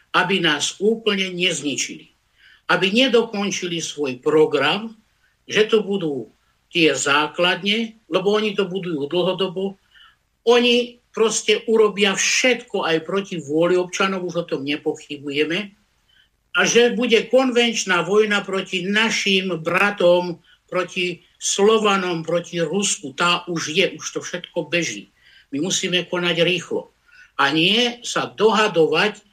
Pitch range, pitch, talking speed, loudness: 170-215 Hz, 190 Hz, 115 wpm, -19 LUFS